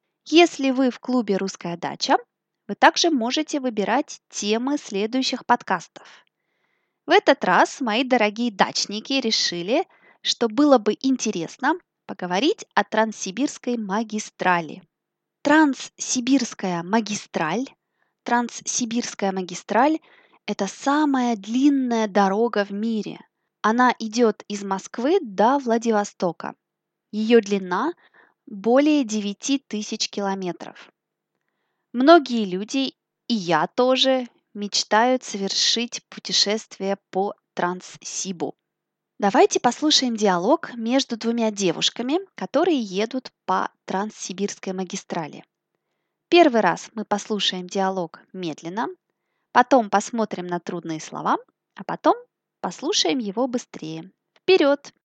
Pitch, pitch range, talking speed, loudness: 230 Hz, 200-270 Hz, 95 wpm, -22 LUFS